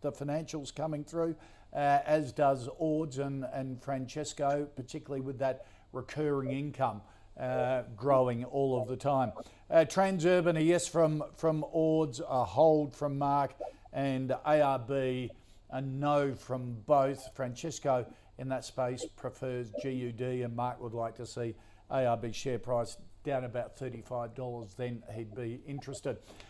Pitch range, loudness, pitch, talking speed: 125-145 Hz, -33 LUFS, 130 Hz, 140 wpm